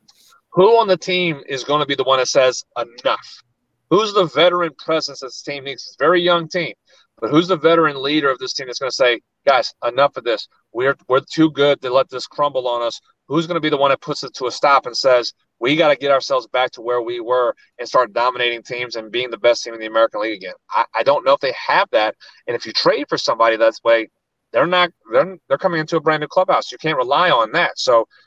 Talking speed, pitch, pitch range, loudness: 260 wpm, 145 Hz, 125-175 Hz, -18 LUFS